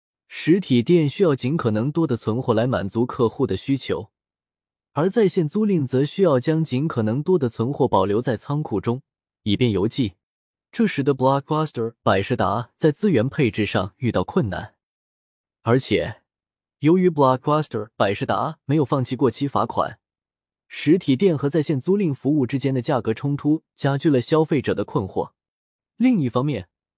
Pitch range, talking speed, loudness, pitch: 115-155 Hz, 285 characters per minute, -21 LUFS, 135 Hz